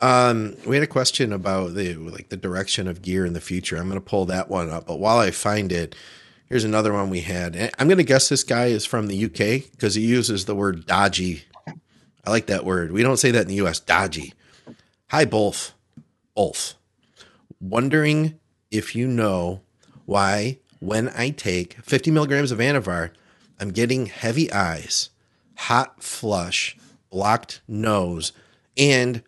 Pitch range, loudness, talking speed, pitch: 95-125 Hz, -22 LUFS, 170 wpm, 105 Hz